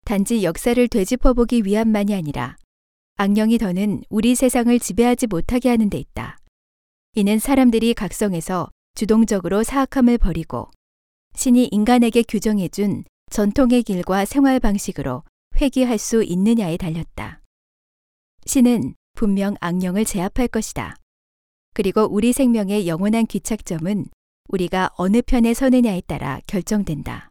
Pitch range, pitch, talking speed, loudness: 180-235 Hz, 210 Hz, 305 characters per minute, -19 LUFS